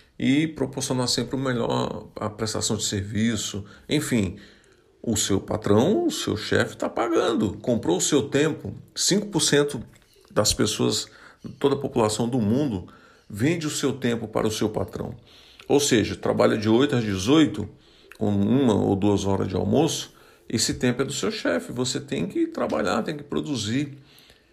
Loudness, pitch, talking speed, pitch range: -24 LUFS, 120 Hz, 160 wpm, 105-145 Hz